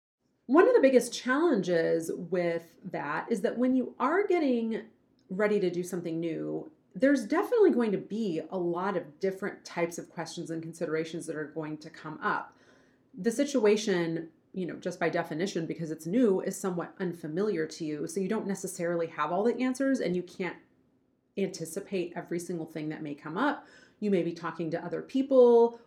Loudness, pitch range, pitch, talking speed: -30 LUFS, 165-235 Hz, 185 Hz, 185 wpm